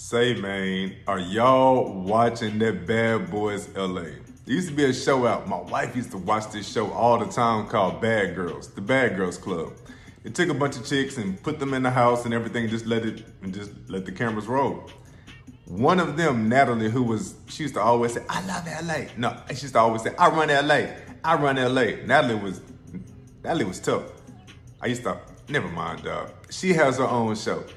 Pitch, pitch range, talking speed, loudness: 120 Hz, 110-140 Hz, 215 wpm, -24 LUFS